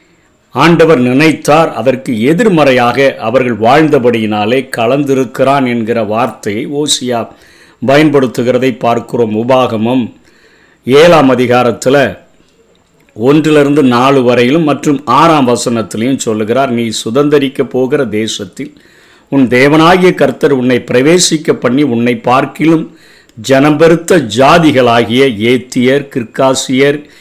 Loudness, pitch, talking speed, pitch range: -9 LUFS, 130 Hz, 85 wpm, 120-145 Hz